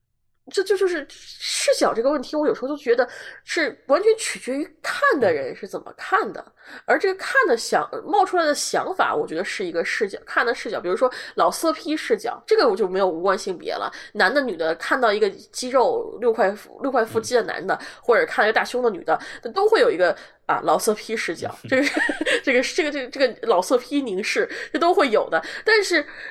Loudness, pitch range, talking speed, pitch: -22 LUFS, 260-440 Hz, 315 characters per minute, 320 Hz